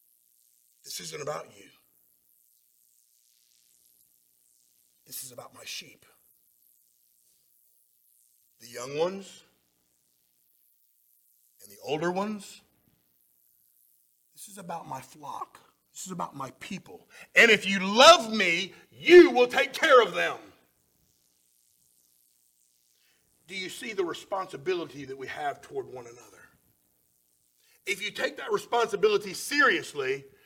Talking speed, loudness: 105 wpm, -24 LUFS